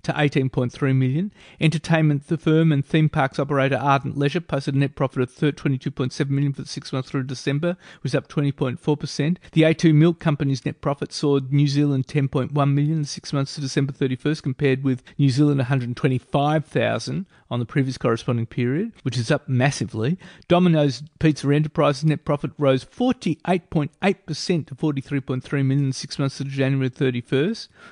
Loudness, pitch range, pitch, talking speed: -22 LUFS, 135-155 Hz, 145 Hz, 170 wpm